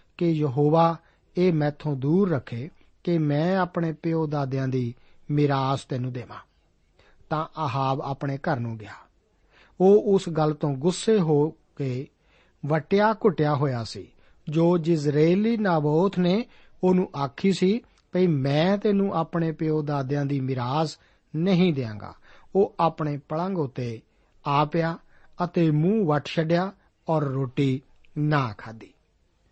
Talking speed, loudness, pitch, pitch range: 125 wpm, -25 LUFS, 155 Hz, 135-175 Hz